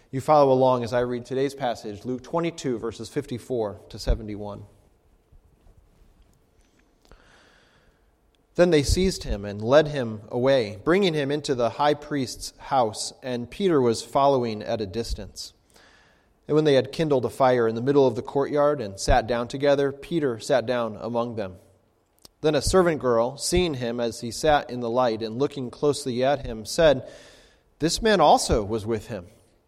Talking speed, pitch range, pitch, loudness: 165 wpm, 115-145 Hz, 125 Hz, -24 LUFS